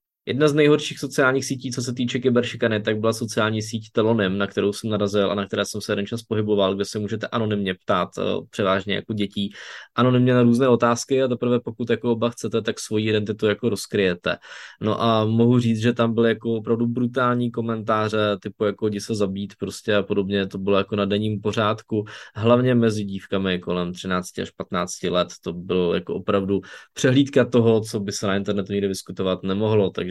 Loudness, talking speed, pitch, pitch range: -22 LUFS, 195 wpm, 110 Hz, 100-120 Hz